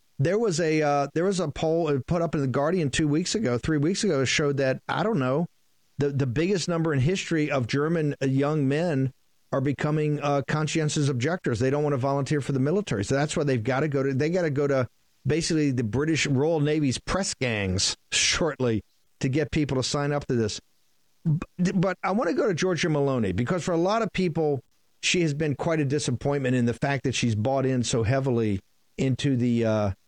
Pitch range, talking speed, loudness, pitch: 130-160 Hz, 215 wpm, -25 LUFS, 145 Hz